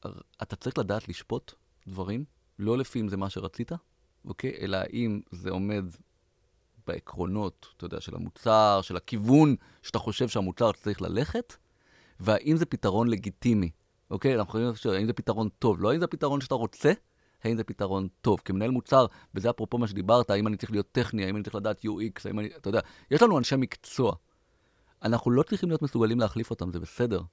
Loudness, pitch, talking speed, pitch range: -28 LUFS, 110 Hz, 180 wpm, 100-120 Hz